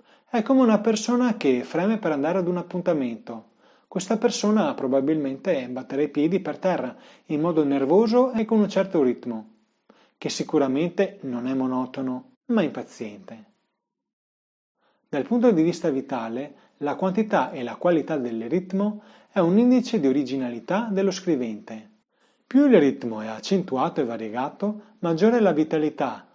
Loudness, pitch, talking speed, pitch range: -23 LUFS, 170 Hz, 150 wpm, 135-215 Hz